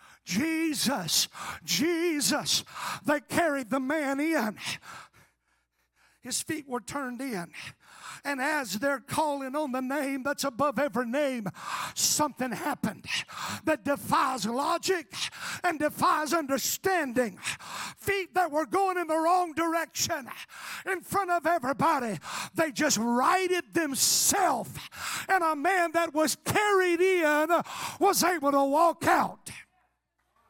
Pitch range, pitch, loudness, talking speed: 275-340 Hz, 305 Hz, -28 LUFS, 115 wpm